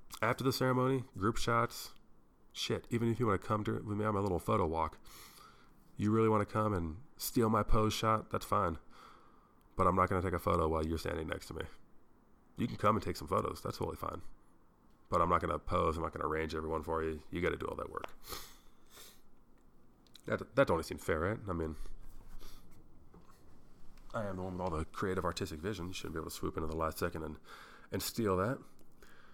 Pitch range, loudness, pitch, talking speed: 80-110 Hz, -35 LUFS, 95 Hz, 225 wpm